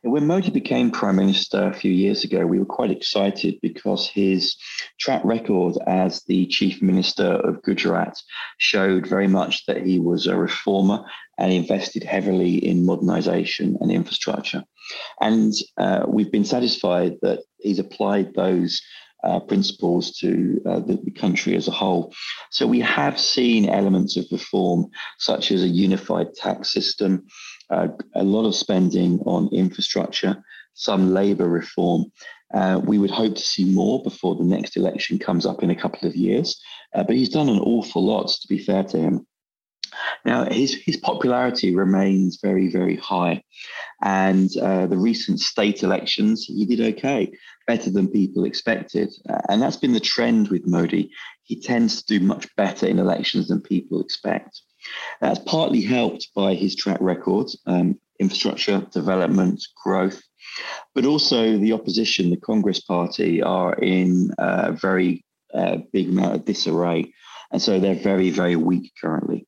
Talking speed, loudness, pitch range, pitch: 160 wpm, -21 LUFS, 95-110 Hz, 95 Hz